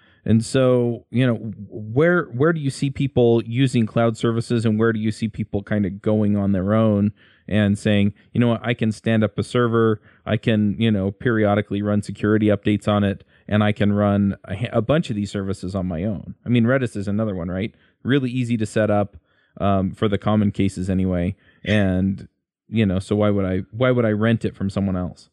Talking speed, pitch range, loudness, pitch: 220 wpm, 100-115 Hz, -21 LUFS, 105 Hz